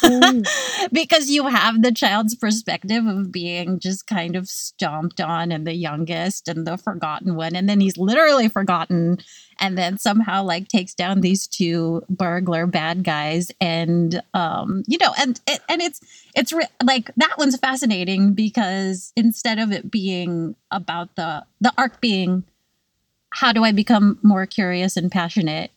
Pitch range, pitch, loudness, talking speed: 175-230 Hz, 195 Hz, -20 LUFS, 160 wpm